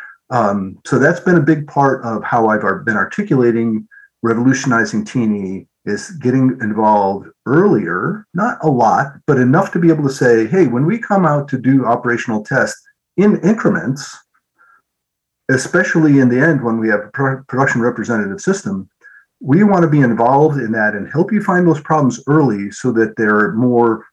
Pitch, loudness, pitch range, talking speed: 130 Hz, -15 LUFS, 110-160 Hz, 170 wpm